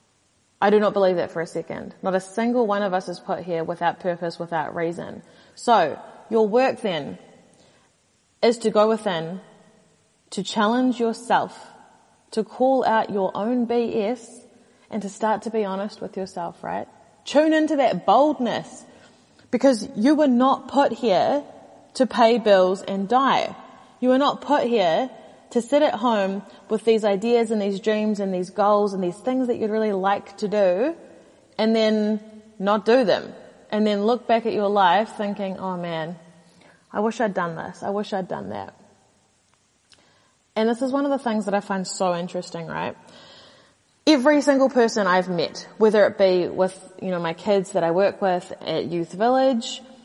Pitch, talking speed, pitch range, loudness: 210 Hz, 175 wpm, 190-240 Hz, -22 LUFS